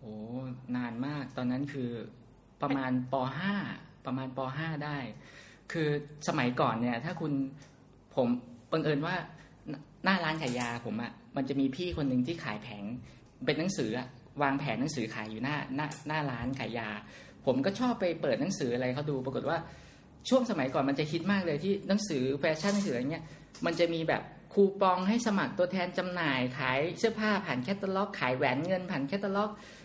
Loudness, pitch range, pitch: -32 LUFS, 125-180 Hz, 145 Hz